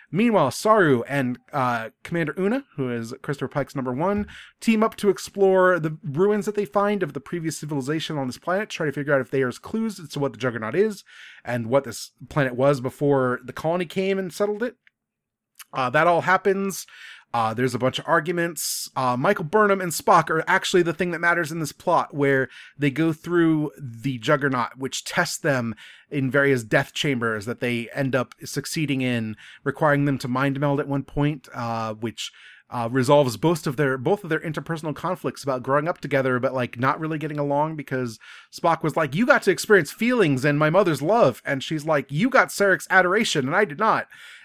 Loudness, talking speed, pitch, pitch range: -23 LUFS, 205 wpm, 150 Hz, 135-175 Hz